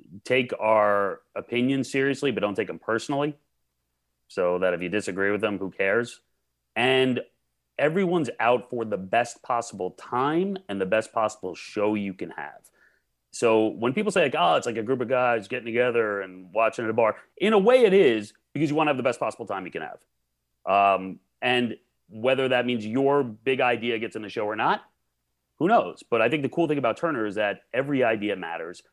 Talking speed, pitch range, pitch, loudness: 205 wpm, 95-130 Hz, 115 Hz, -25 LUFS